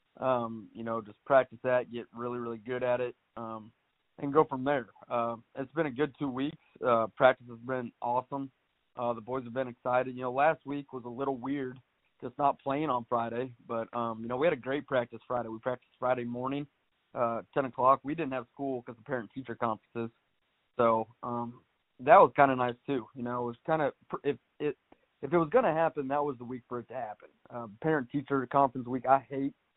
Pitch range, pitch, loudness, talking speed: 120-140 Hz, 125 Hz, -31 LUFS, 230 wpm